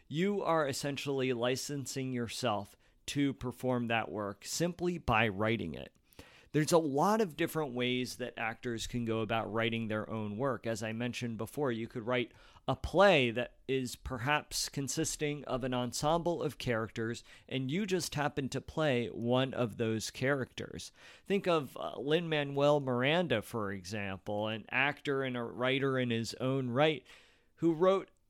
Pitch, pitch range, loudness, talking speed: 125 Hz, 115-145 Hz, -33 LUFS, 155 wpm